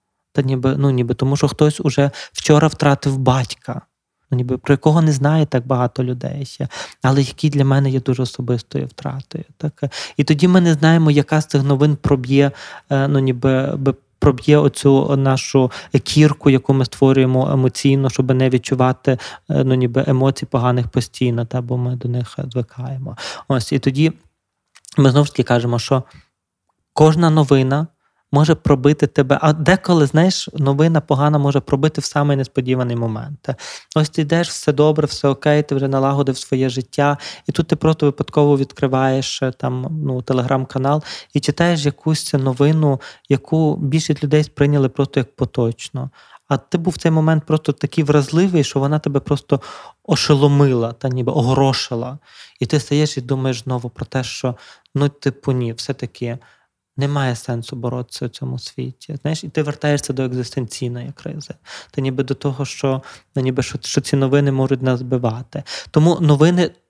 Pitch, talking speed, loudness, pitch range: 140 Hz, 160 wpm, -17 LUFS, 130-150 Hz